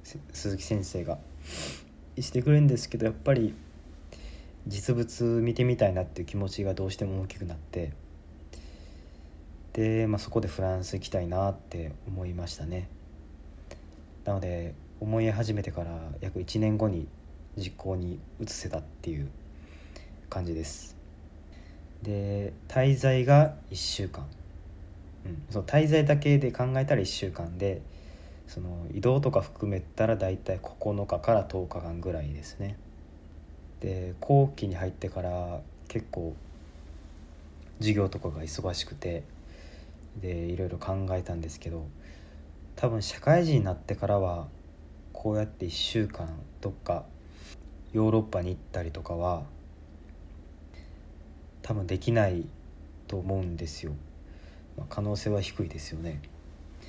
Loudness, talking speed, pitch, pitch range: -30 LUFS, 240 characters per minute, 85 Hz, 75-100 Hz